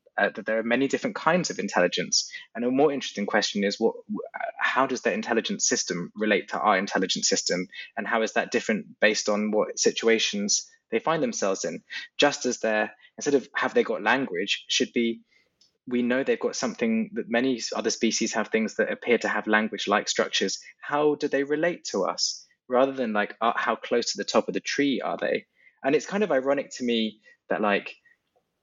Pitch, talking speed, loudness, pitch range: 120 Hz, 205 wpm, -25 LUFS, 110-170 Hz